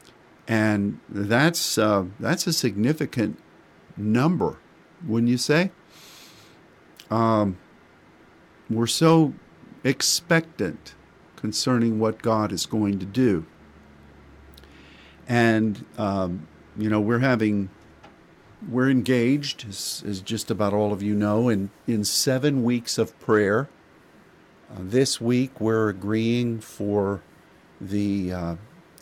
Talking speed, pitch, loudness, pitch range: 105 wpm, 110 Hz, -23 LUFS, 100-125 Hz